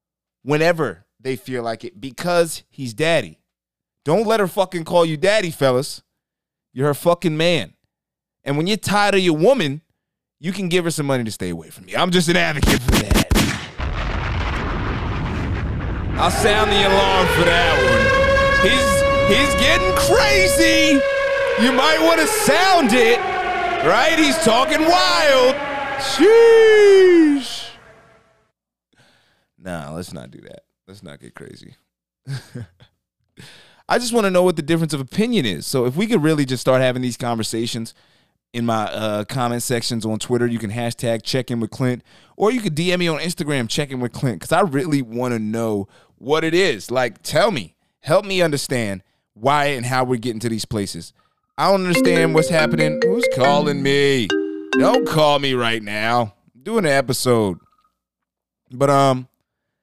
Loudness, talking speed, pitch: -17 LUFS, 165 wpm, 145 Hz